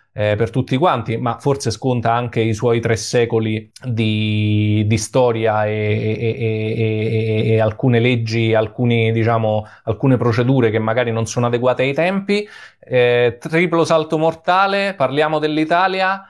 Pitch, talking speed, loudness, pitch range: 115 Hz, 145 wpm, -17 LUFS, 110-135 Hz